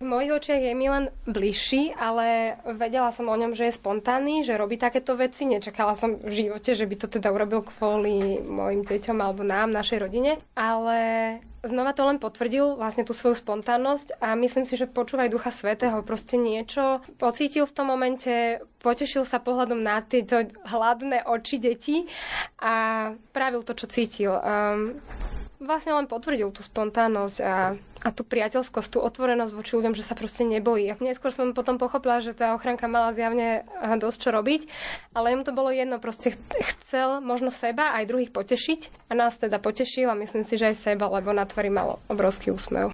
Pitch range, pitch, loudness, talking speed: 220-255 Hz, 235 Hz, -26 LUFS, 180 wpm